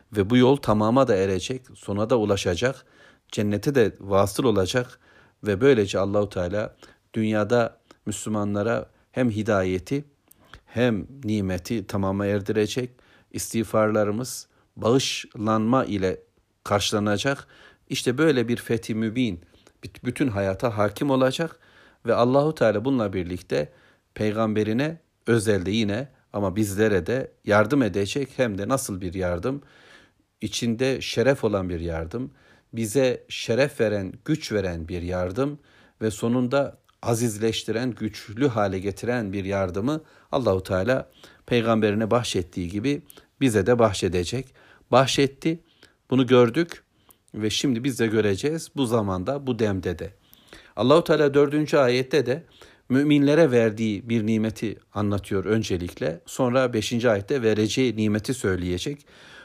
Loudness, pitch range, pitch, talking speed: -24 LUFS, 100-130 Hz, 110 Hz, 115 wpm